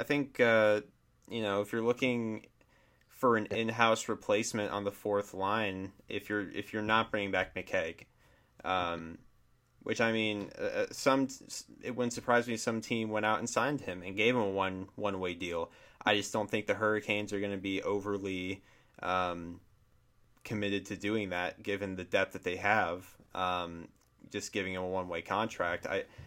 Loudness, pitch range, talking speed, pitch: -33 LUFS, 95-110 Hz, 180 wpm, 105 Hz